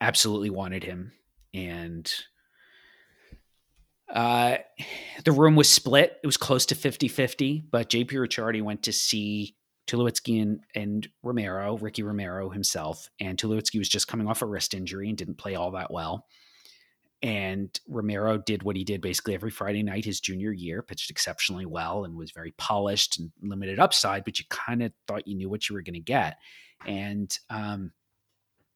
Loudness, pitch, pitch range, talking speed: -27 LUFS, 105 Hz, 95-115 Hz, 165 wpm